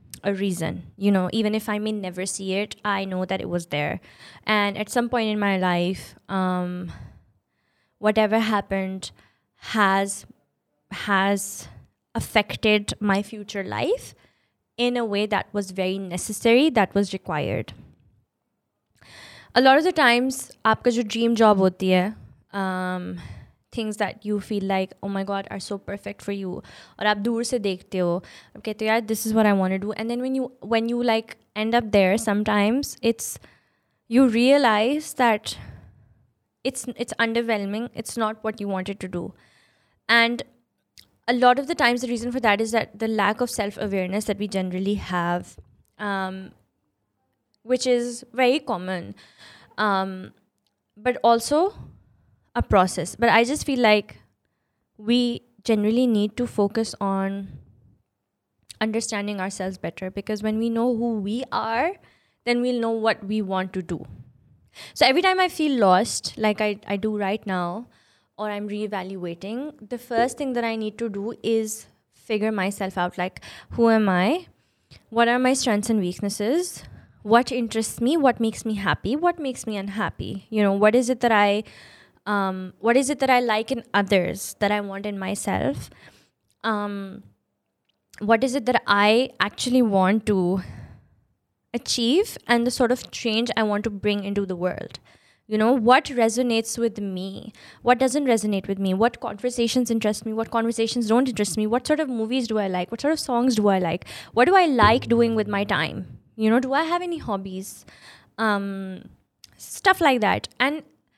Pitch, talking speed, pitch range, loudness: 215 Hz, 165 wpm, 195-235 Hz, -23 LUFS